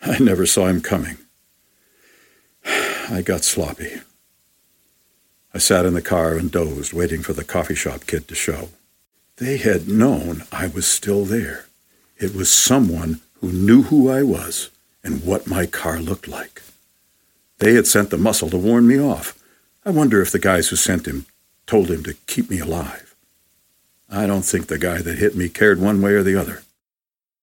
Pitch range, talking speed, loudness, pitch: 85-105 Hz, 175 wpm, -18 LUFS, 95 Hz